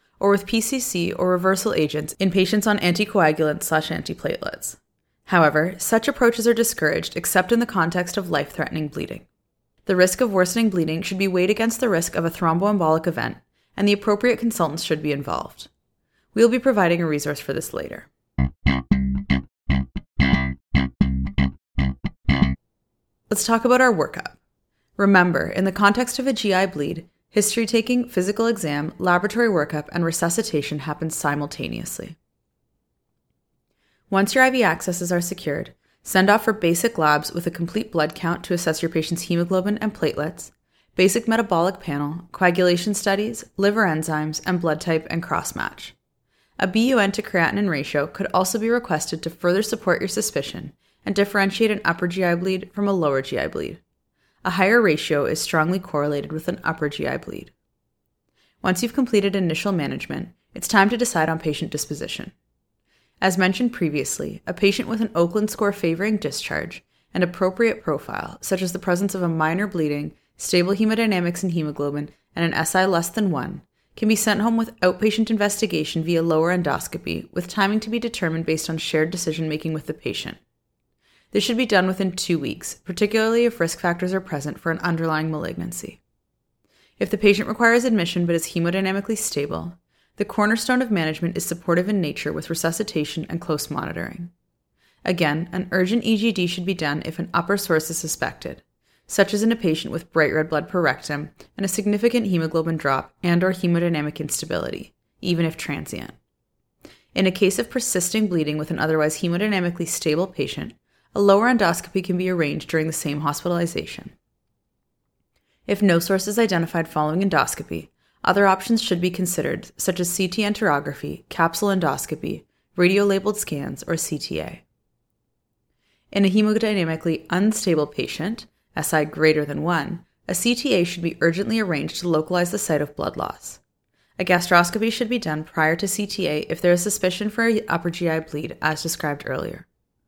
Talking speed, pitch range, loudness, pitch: 160 wpm, 160-205 Hz, -22 LUFS, 180 Hz